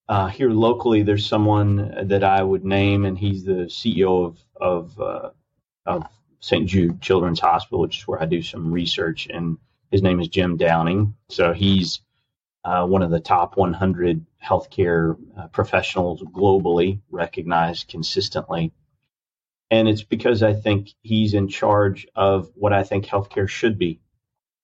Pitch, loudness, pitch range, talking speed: 95 Hz, -21 LUFS, 90-105 Hz, 150 wpm